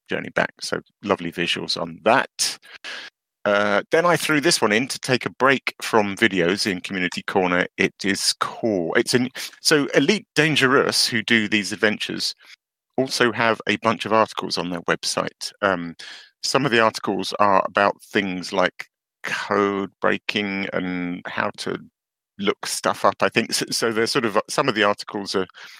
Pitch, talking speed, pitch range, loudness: 105 Hz, 170 wpm, 95-115 Hz, -21 LUFS